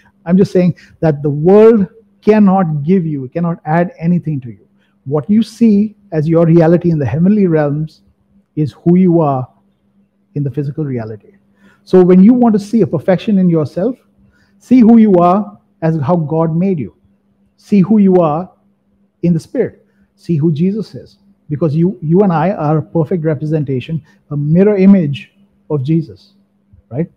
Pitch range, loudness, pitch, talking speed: 155-200 Hz, -12 LUFS, 175 Hz, 170 wpm